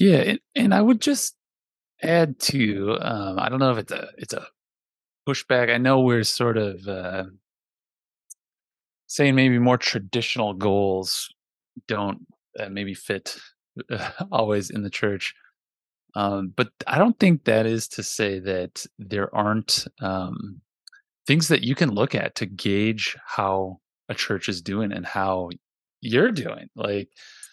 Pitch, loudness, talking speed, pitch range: 110 Hz, -23 LUFS, 145 wpm, 100-130 Hz